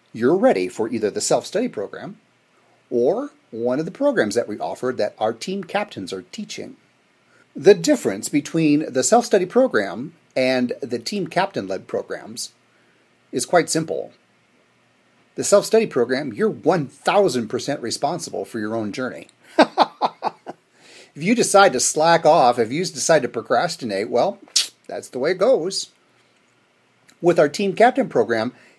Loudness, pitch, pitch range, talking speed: -20 LUFS, 175 Hz, 130-215 Hz, 150 wpm